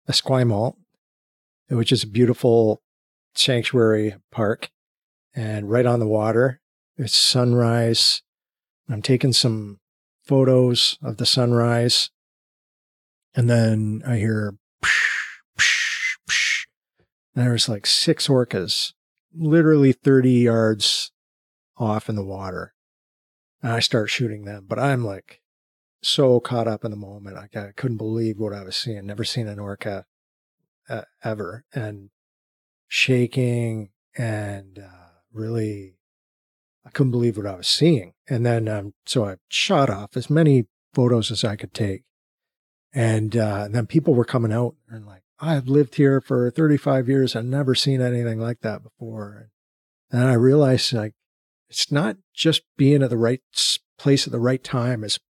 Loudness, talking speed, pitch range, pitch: -20 LUFS, 140 wpm, 105-130 Hz, 115 Hz